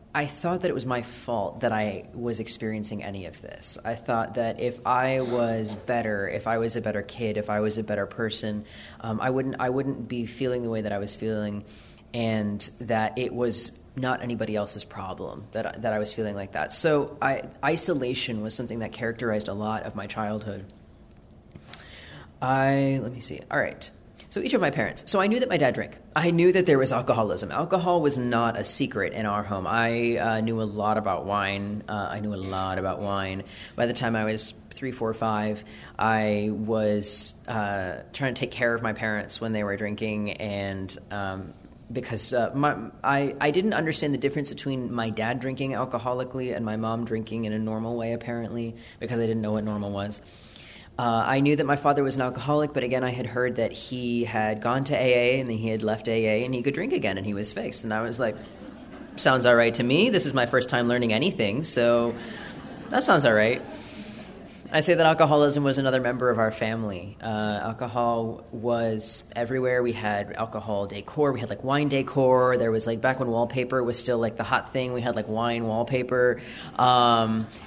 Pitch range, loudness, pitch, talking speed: 105-125 Hz, -26 LUFS, 115 Hz, 210 wpm